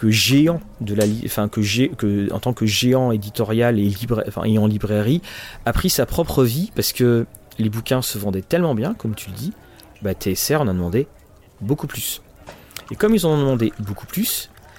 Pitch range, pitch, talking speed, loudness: 105-135 Hz, 110 Hz, 205 wpm, -20 LUFS